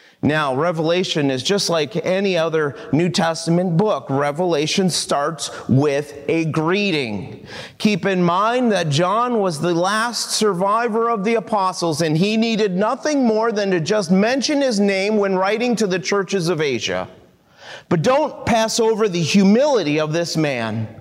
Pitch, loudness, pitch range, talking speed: 190 Hz, -18 LUFS, 165-215 Hz, 155 wpm